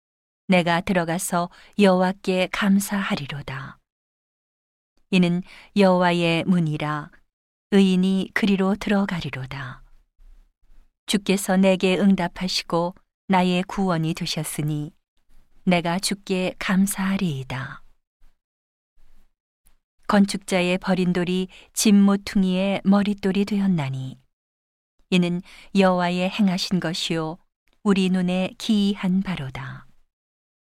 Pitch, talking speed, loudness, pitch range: 185 Hz, 210 characters per minute, -22 LUFS, 155-195 Hz